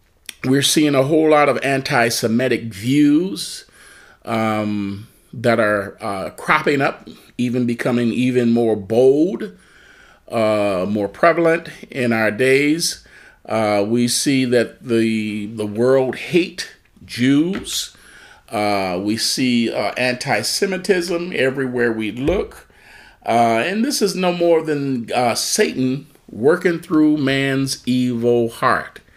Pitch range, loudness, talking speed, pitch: 115-145 Hz, -18 LUFS, 115 wpm, 125 Hz